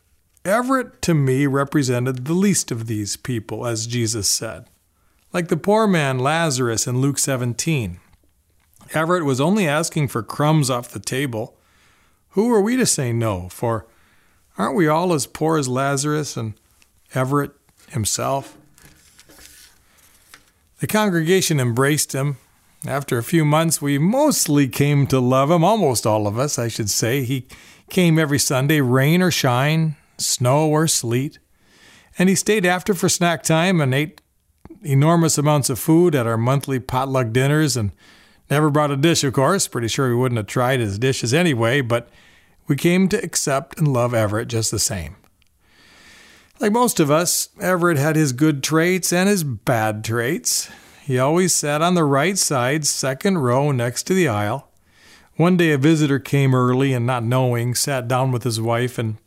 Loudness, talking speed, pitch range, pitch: -19 LUFS, 165 wpm, 120-160 Hz, 140 Hz